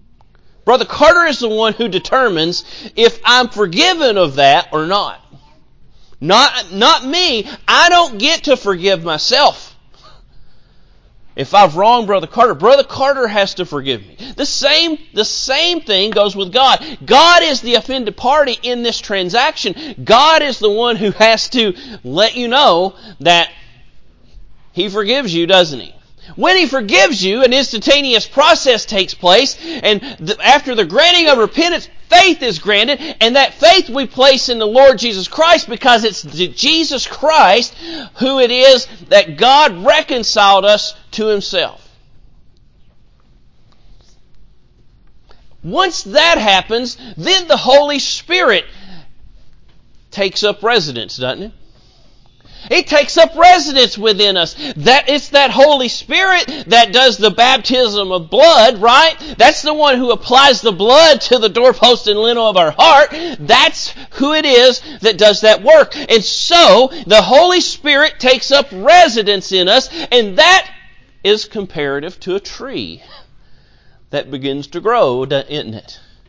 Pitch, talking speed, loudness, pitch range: 250 Hz, 145 wpm, -11 LUFS, 210-300 Hz